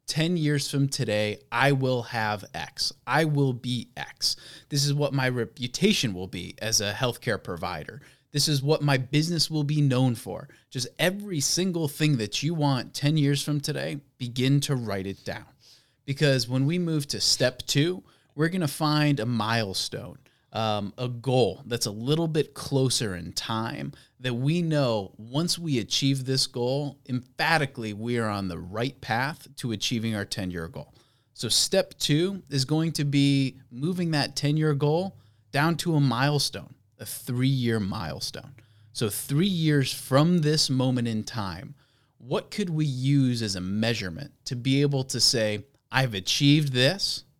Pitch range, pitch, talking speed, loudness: 115-145 Hz, 135 Hz, 165 wpm, -26 LUFS